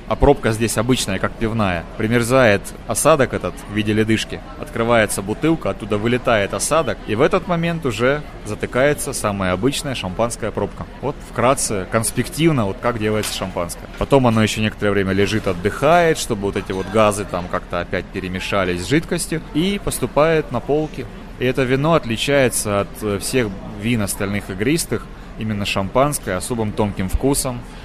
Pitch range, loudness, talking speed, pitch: 100-130 Hz, -19 LUFS, 150 wpm, 110 Hz